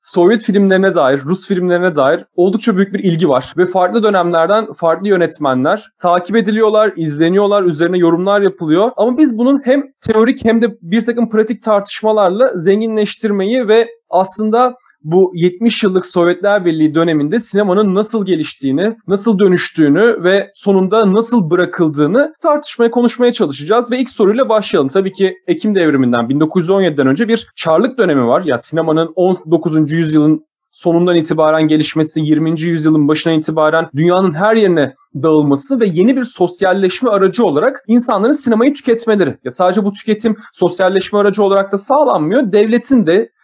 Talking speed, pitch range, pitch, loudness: 145 wpm, 170-225 Hz, 195 Hz, -13 LUFS